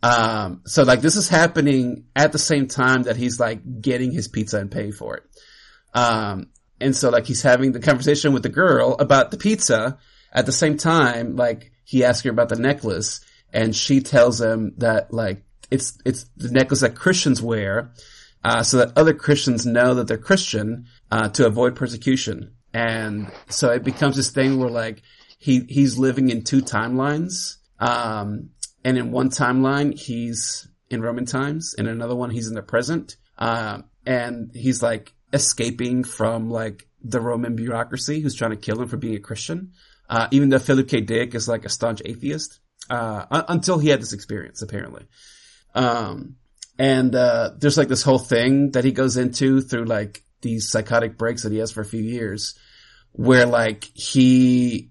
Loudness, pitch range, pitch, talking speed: -20 LUFS, 115-135 Hz, 125 Hz, 180 wpm